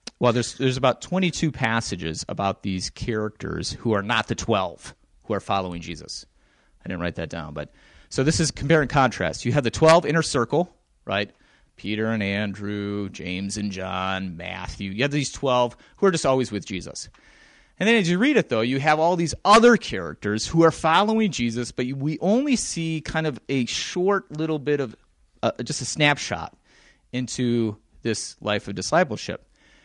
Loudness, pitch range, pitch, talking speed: -23 LUFS, 100-155 Hz, 120 Hz, 185 wpm